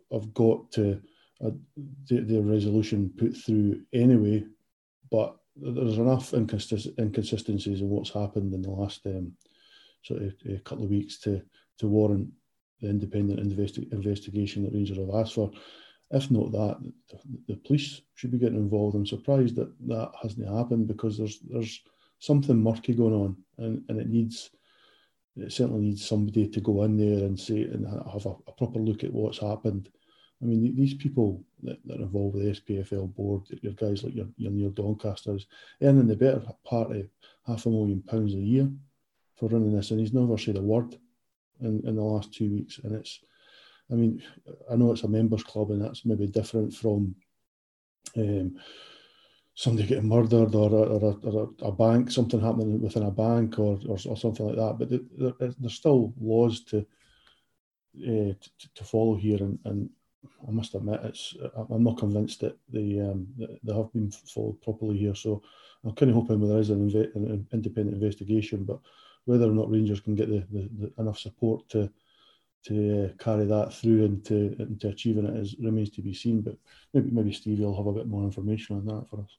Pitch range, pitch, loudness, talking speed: 105-115 Hz, 110 Hz, -28 LUFS, 190 wpm